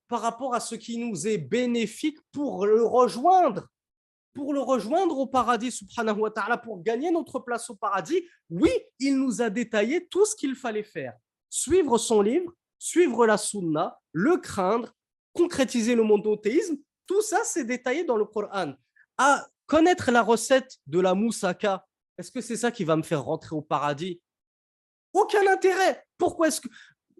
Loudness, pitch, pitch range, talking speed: -25 LUFS, 240 Hz, 210-310 Hz, 170 wpm